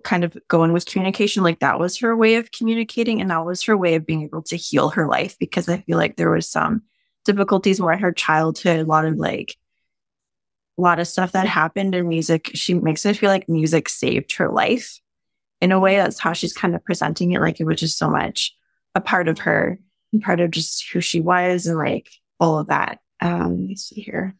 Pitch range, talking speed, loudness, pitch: 165-195 Hz, 225 wpm, -20 LUFS, 180 Hz